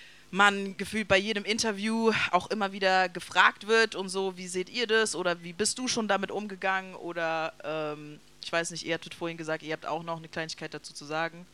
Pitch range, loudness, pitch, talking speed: 165-205 Hz, -29 LUFS, 185 Hz, 215 wpm